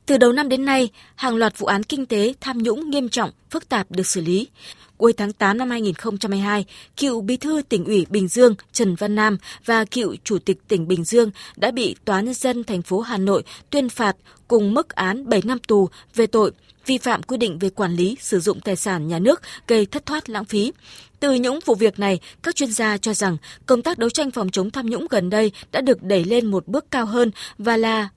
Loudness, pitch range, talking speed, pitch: -20 LUFS, 200-250 Hz, 230 wpm, 220 Hz